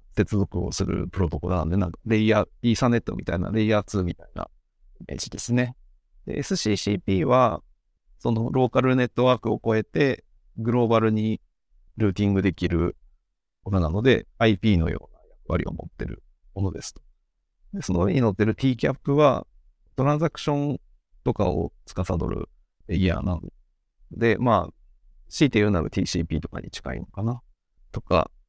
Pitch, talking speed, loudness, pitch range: 105 Hz, 340 characters per minute, -24 LUFS, 85-120 Hz